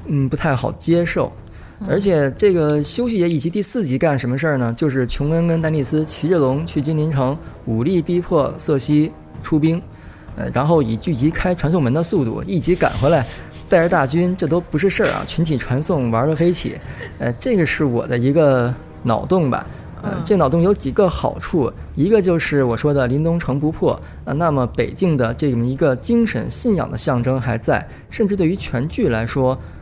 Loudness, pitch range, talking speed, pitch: -18 LUFS, 130-170 Hz, 290 characters per minute, 155 Hz